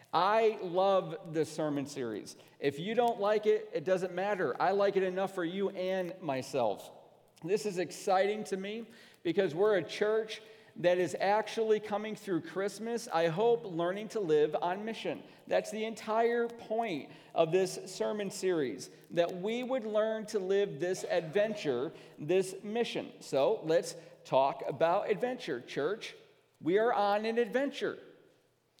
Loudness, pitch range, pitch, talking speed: -33 LUFS, 185-220 Hz, 205 Hz, 150 wpm